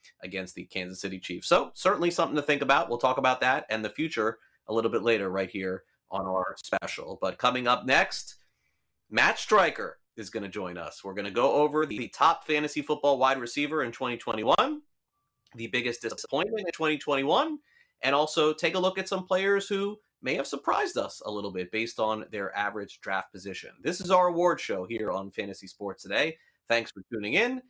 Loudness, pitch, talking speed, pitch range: -28 LUFS, 130 Hz, 200 wpm, 105-155 Hz